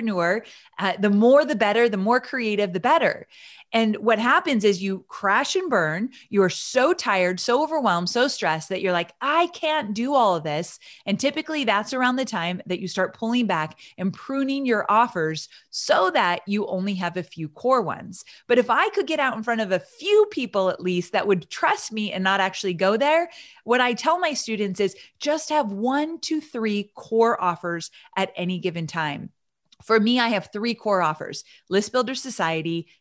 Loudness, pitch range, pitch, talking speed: -23 LUFS, 185-255 Hz, 210 Hz, 200 wpm